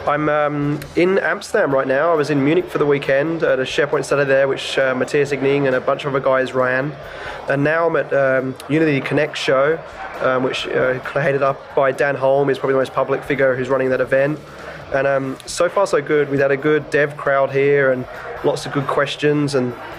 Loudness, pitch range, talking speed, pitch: -18 LUFS, 135-145 Hz, 220 wpm, 140 Hz